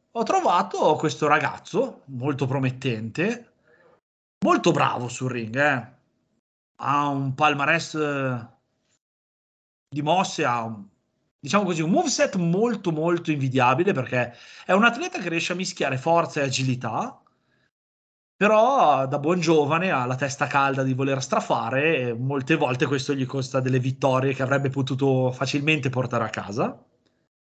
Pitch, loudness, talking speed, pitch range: 140 Hz, -23 LUFS, 135 wpm, 130-160 Hz